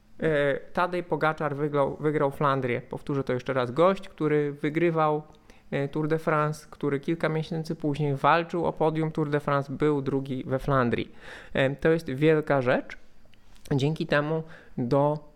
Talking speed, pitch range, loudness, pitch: 140 wpm, 140-160 Hz, -27 LUFS, 150 Hz